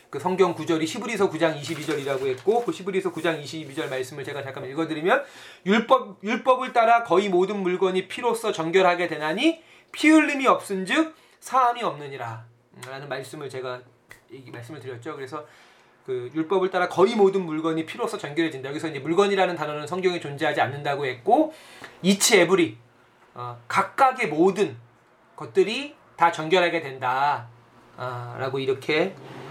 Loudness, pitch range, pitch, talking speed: -23 LUFS, 140-205 Hz, 170 Hz, 325 characters per minute